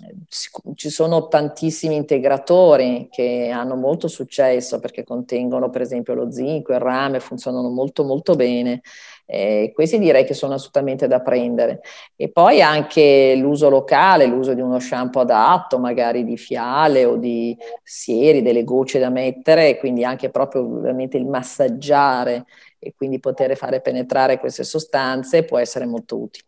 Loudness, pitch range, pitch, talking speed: -18 LUFS, 125-140 Hz, 130 Hz, 150 wpm